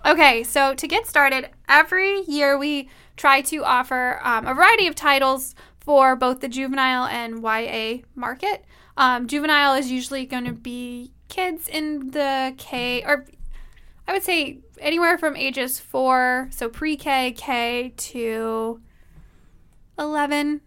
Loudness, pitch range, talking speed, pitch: -20 LUFS, 250-295 Hz, 140 wpm, 270 Hz